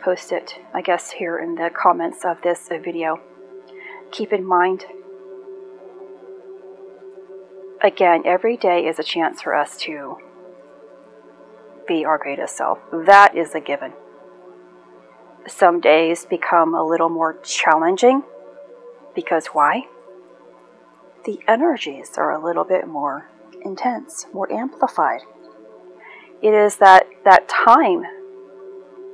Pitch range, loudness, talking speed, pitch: 165-205 Hz, -18 LUFS, 115 wpm, 185 Hz